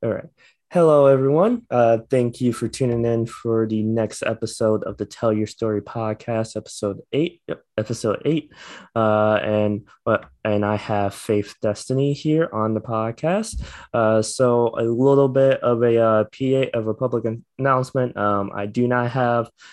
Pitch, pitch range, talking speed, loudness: 115 Hz, 110-130 Hz, 165 wpm, -21 LUFS